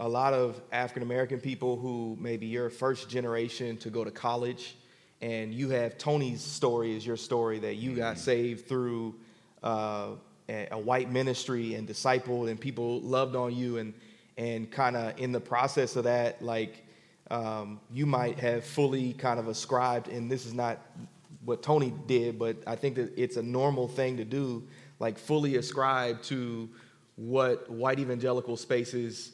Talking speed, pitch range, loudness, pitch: 165 wpm, 115-130 Hz, -31 LUFS, 120 Hz